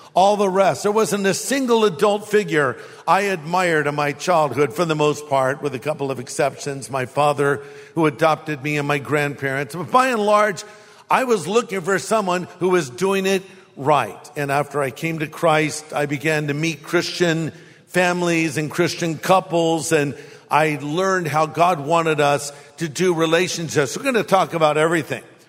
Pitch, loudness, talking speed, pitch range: 160 Hz, -20 LUFS, 180 wpm, 145-185 Hz